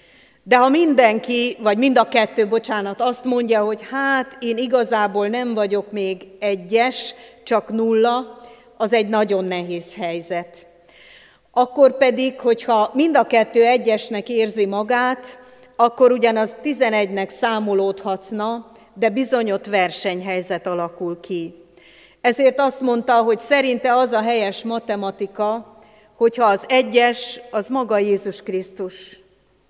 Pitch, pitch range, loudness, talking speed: 225 Hz, 200-245 Hz, -19 LUFS, 120 wpm